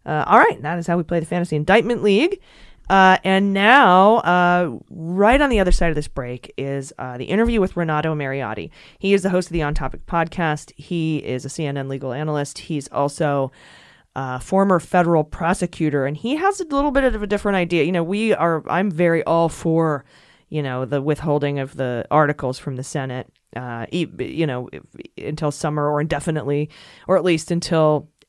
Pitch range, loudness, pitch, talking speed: 145-185 Hz, -19 LUFS, 160 Hz, 195 wpm